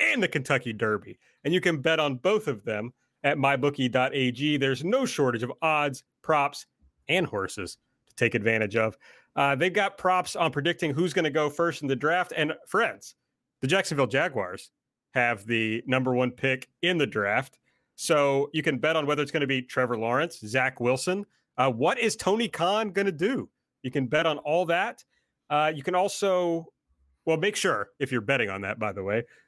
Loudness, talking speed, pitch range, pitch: -26 LUFS, 190 wpm, 125-170 Hz, 145 Hz